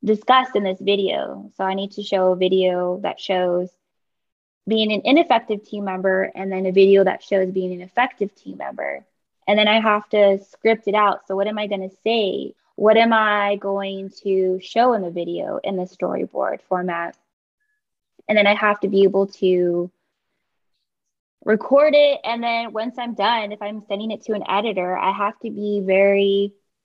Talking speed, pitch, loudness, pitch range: 190 wpm, 200 Hz, -20 LUFS, 190-215 Hz